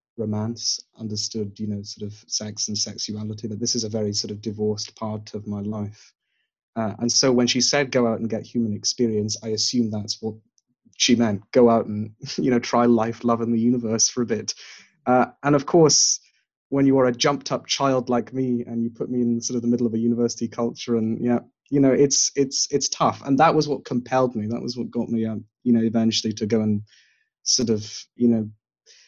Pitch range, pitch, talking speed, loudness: 110-125 Hz, 115 Hz, 225 wpm, -22 LUFS